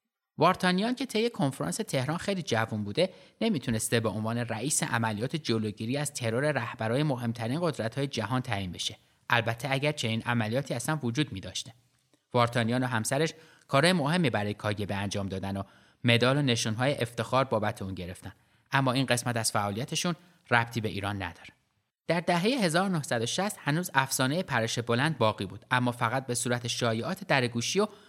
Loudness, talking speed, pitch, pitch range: -29 LUFS, 155 wpm, 120 Hz, 115-150 Hz